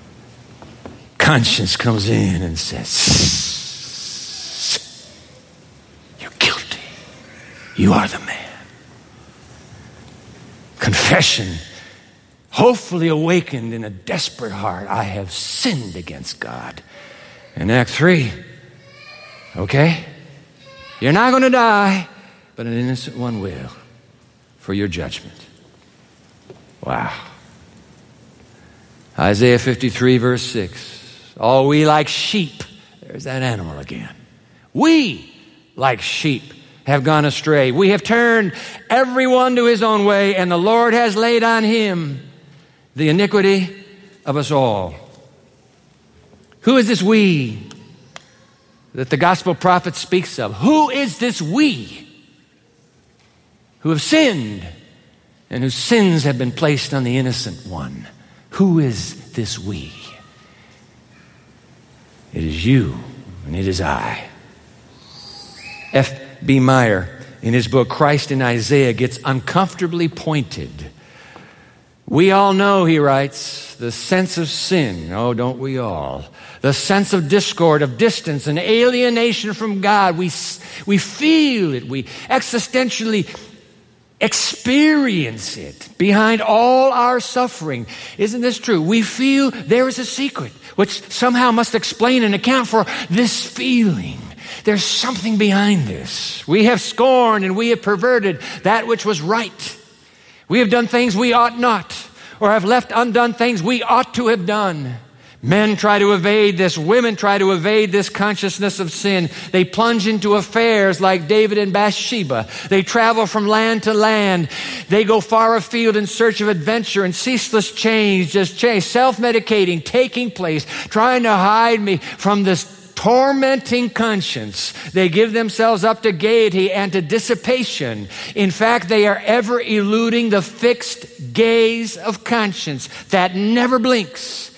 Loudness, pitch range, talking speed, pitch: -16 LUFS, 135-225 Hz, 130 wpm, 195 Hz